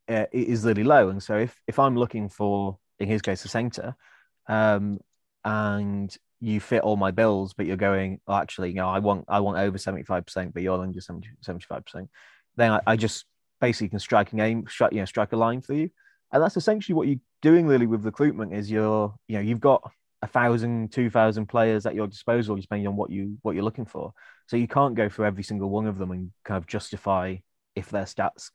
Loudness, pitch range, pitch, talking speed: -25 LUFS, 100-115 Hz, 105 Hz, 225 wpm